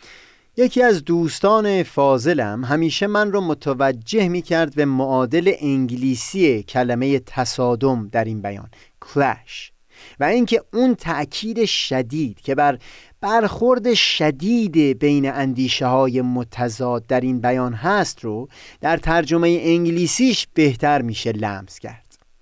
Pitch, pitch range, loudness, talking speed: 140 Hz, 125-170 Hz, -19 LUFS, 120 wpm